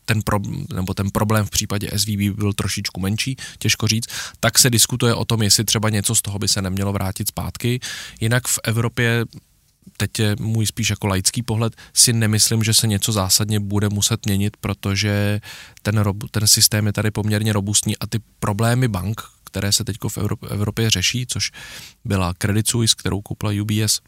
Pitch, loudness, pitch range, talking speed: 105 Hz, -19 LUFS, 100-115 Hz, 180 wpm